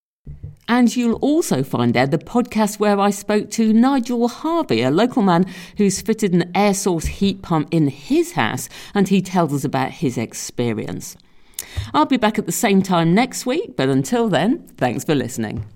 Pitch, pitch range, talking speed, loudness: 195 Hz, 145-230 Hz, 185 wpm, -19 LUFS